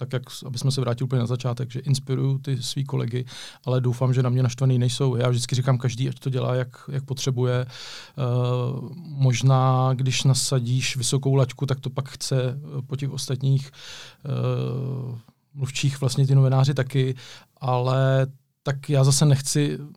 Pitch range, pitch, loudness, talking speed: 125-135 Hz, 130 Hz, -24 LUFS, 165 wpm